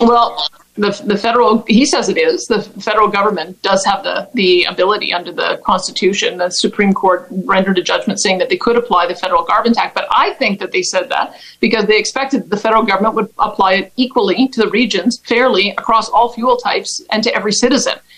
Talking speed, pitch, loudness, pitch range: 210 wpm, 215 Hz, -14 LUFS, 195-240 Hz